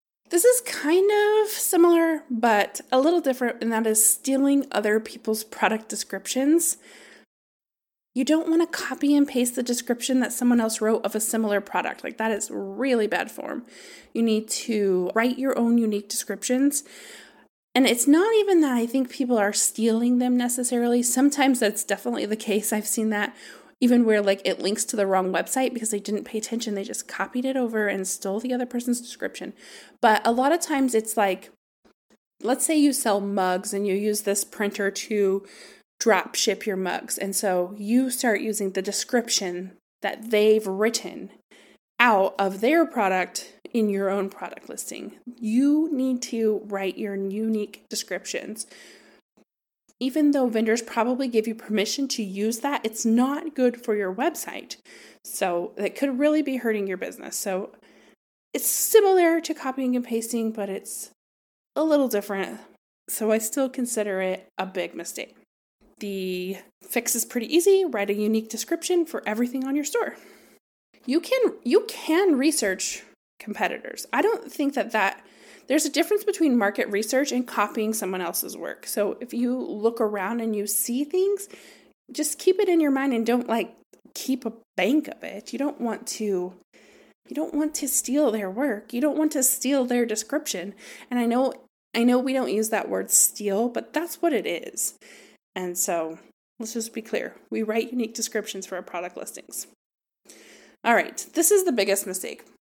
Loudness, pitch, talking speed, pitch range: -24 LUFS, 230 Hz, 175 wpm, 205-275 Hz